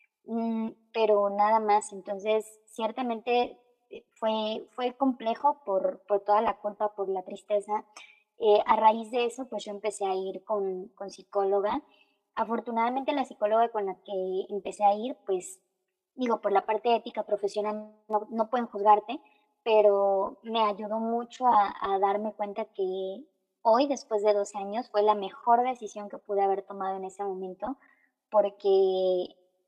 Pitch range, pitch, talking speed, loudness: 200-230 Hz, 210 Hz, 150 wpm, -28 LUFS